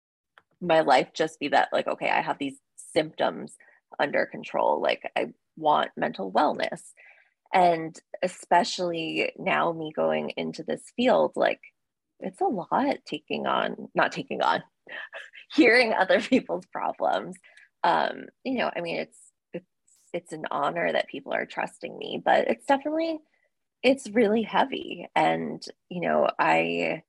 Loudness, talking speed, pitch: -26 LUFS, 140 wpm, 175 Hz